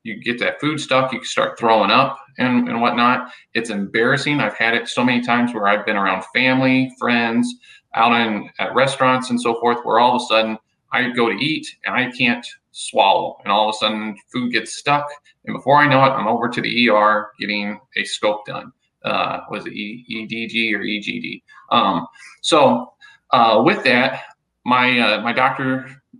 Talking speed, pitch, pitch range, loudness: 205 wpm, 120 Hz, 110-130 Hz, -18 LUFS